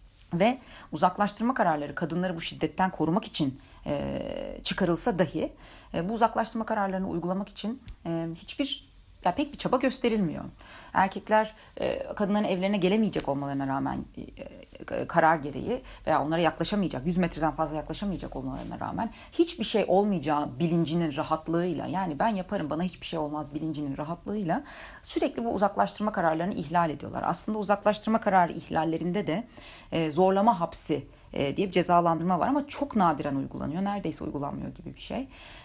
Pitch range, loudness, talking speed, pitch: 160-215 Hz, -29 LUFS, 135 wpm, 185 Hz